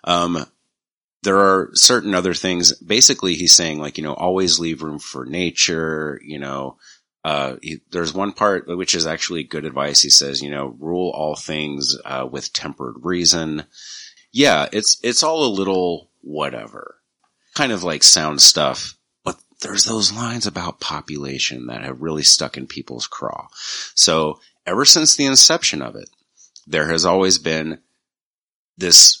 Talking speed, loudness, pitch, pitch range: 160 wpm, -15 LUFS, 80 Hz, 75-95 Hz